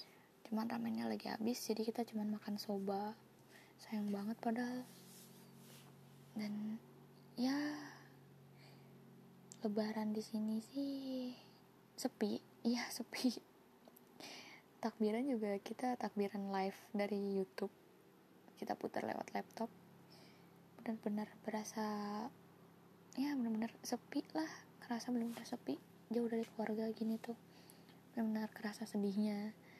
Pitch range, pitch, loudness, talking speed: 200-230 Hz, 215 Hz, -43 LUFS, 100 wpm